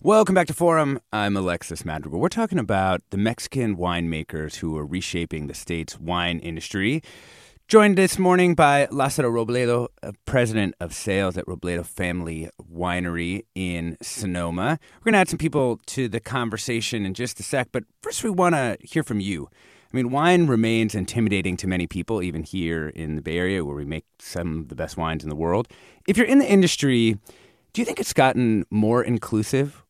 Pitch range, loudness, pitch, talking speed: 85-130 Hz, -23 LUFS, 105 Hz, 190 wpm